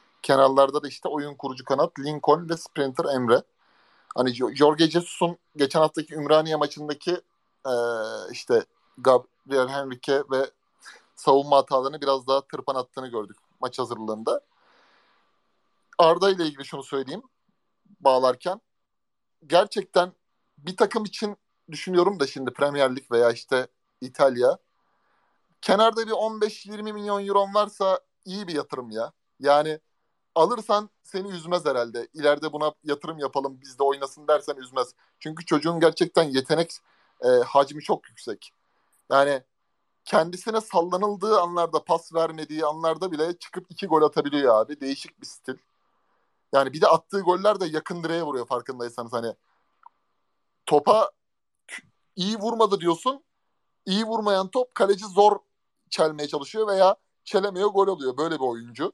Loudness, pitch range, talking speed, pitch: -24 LUFS, 140-190 Hz, 130 wpm, 155 Hz